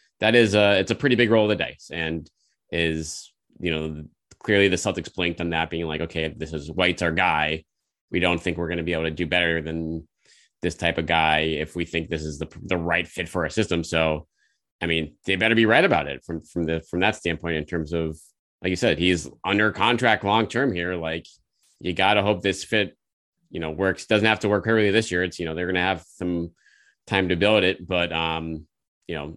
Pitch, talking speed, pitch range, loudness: 85 Hz, 240 wpm, 80-95 Hz, -23 LUFS